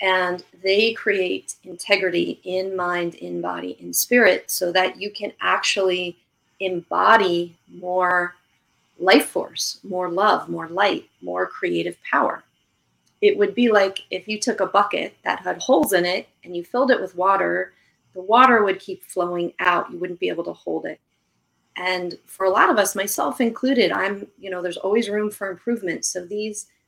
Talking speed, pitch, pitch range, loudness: 170 wpm, 185 Hz, 175-205 Hz, -21 LUFS